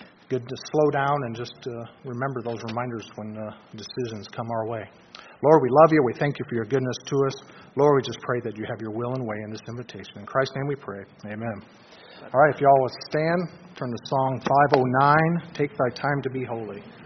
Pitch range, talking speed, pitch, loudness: 115-140 Hz, 230 wpm, 125 Hz, -24 LUFS